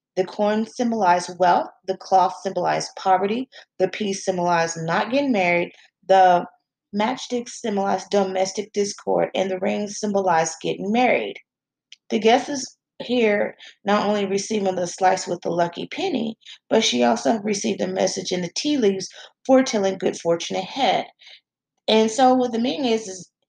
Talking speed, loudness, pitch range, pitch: 150 wpm, -22 LUFS, 185-225 Hz, 195 Hz